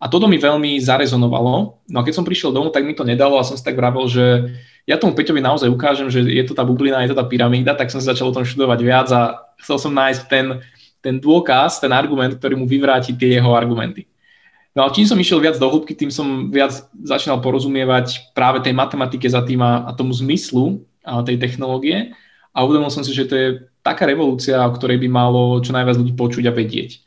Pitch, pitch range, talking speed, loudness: 130 Hz, 125-140 Hz, 225 wpm, -16 LUFS